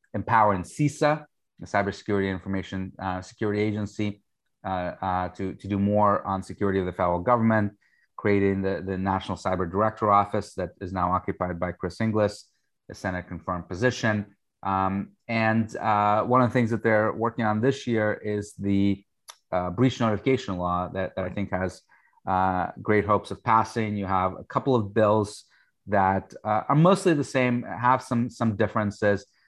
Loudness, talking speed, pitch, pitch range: -26 LUFS, 170 wpm, 100 Hz, 95-110 Hz